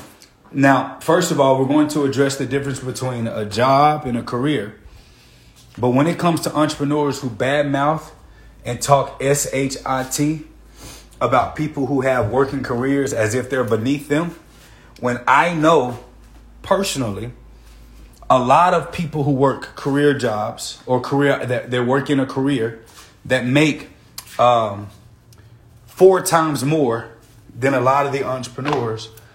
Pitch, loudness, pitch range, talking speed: 135 Hz, -18 LUFS, 120-145 Hz, 145 wpm